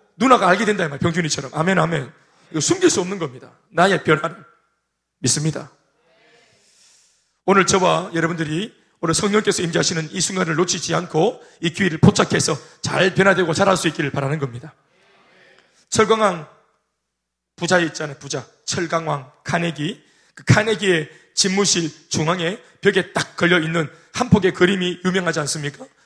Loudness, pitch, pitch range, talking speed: -19 LUFS, 170 Hz, 155-190 Hz, 325 characters per minute